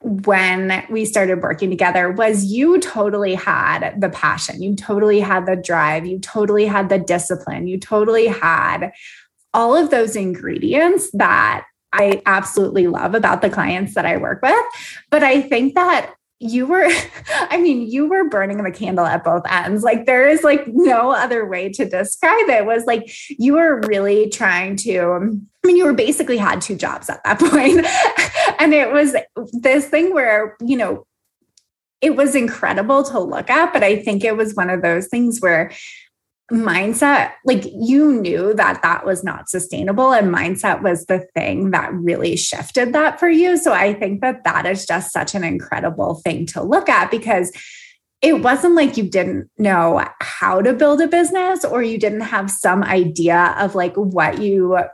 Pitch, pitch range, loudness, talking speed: 215 Hz, 190-280 Hz, -16 LUFS, 180 wpm